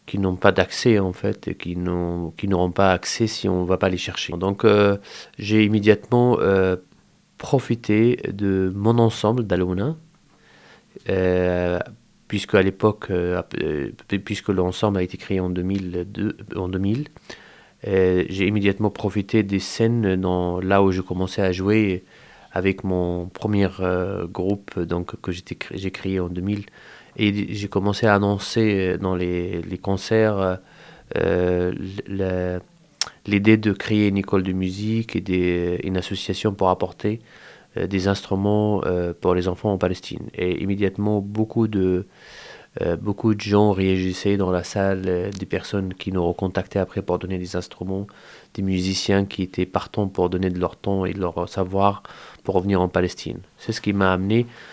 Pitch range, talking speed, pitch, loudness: 90-105 Hz, 160 wpm, 95 Hz, -22 LUFS